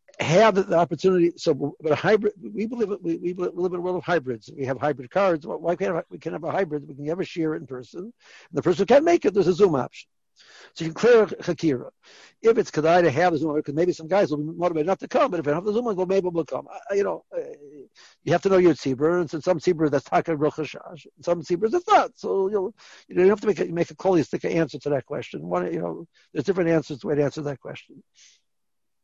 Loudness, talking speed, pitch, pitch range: -23 LUFS, 285 wpm, 175 Hz, 155-195 Hz